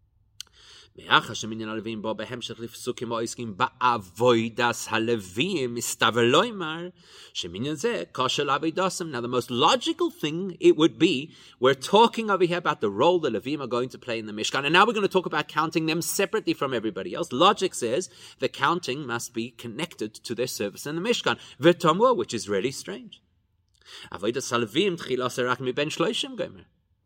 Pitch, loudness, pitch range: 125 Hz, -25 LUFS, 115-170 Hz